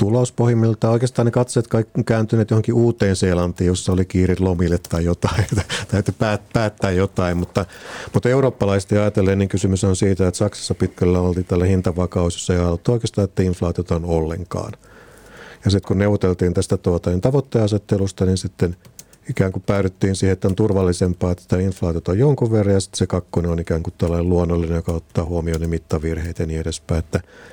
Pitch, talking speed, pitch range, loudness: 95 Hz, 175 wpm, 90-105 Hz, -19 LUFS